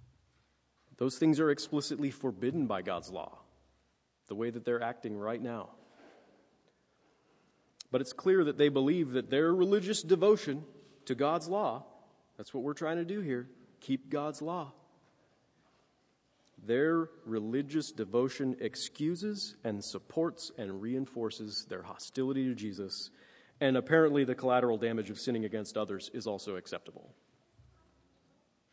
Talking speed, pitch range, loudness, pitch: 130 wpm, 115-155 Hz, -33 LUFS, 130 Hz